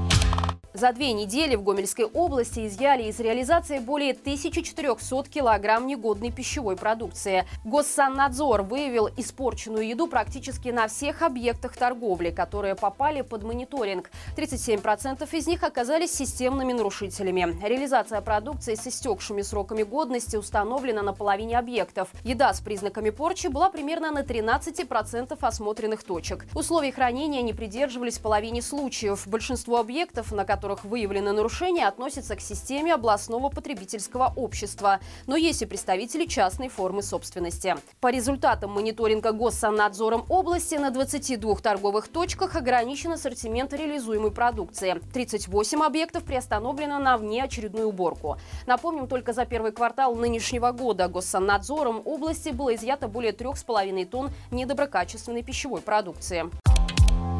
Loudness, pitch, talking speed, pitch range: -26 LUFS, 240 Hz, 120 wpm, 210-280 Hz